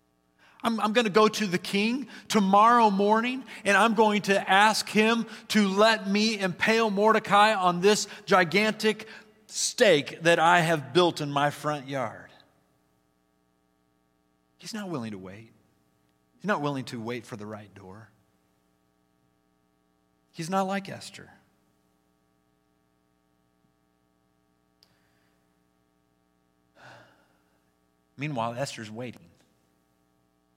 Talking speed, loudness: 105 wpm, -24 LUFS